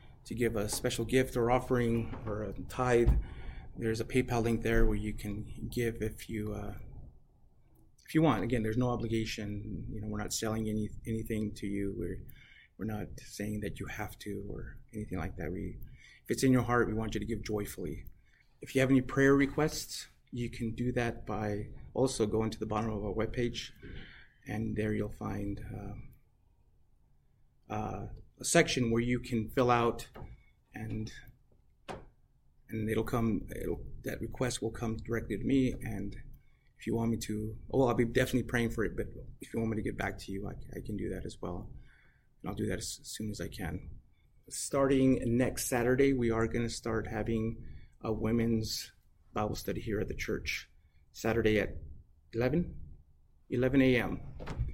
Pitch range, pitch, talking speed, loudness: 105-120 Hz, 110 Hz, 185 wpm, -33 LUFS